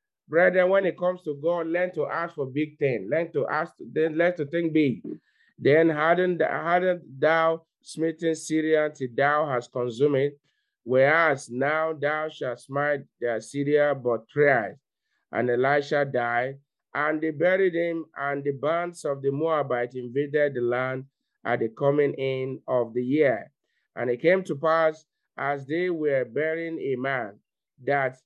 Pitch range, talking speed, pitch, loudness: 135-160 Hz, 155 wpm, 145 Hz, -25 LUFS